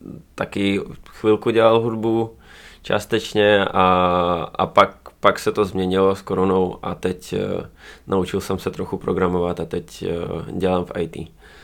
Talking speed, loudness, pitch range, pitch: 135 wpm, -20 LUFS, 95-105 Hz, 95 Hz